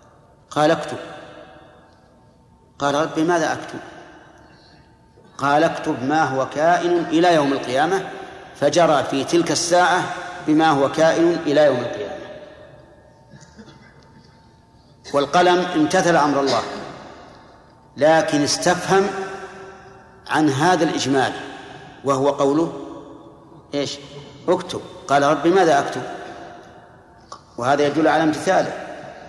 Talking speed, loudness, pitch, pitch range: 90 wpm, -19 LUFS, 160 Hz, 145-180 Hz